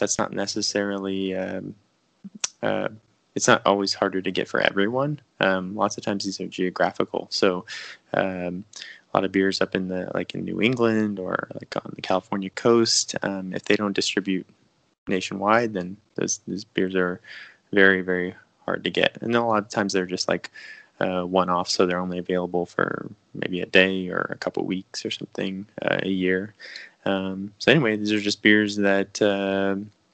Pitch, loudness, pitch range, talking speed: 95 Hz, -24 LUFS, 95-105 Hz, 185 wpm